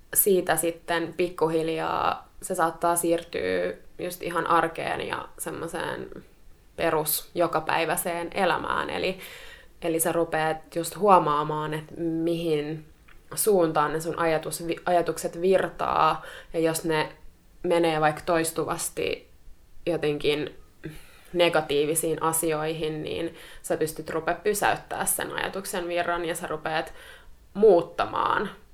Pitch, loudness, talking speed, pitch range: 165 Hz, -26 LUFS, 100 wpm, 155-175 Hz